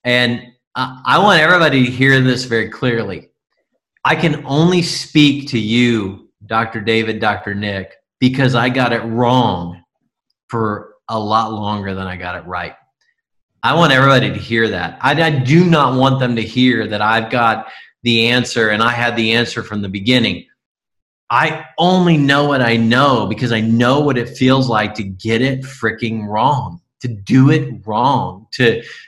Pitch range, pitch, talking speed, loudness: 110-135 Hz, 120 Hz, 170 wpm, -15 LUFS